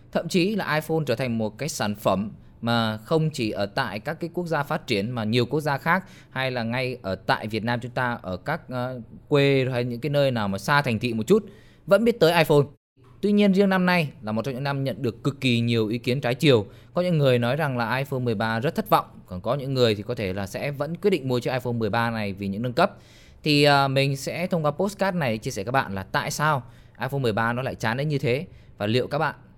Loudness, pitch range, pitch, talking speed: -24 LUFS, 115-150 Hz, 130 Hz, 265 wpm